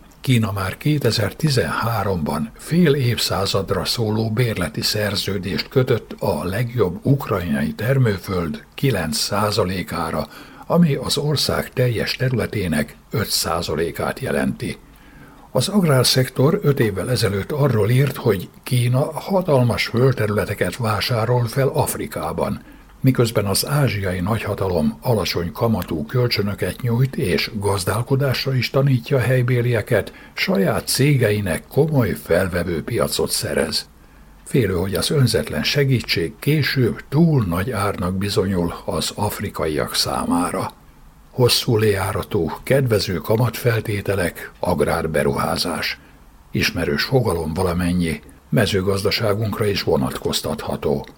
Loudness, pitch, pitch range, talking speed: -20 LUFS, 115 Hz, 100-130 Hz, 95 wpm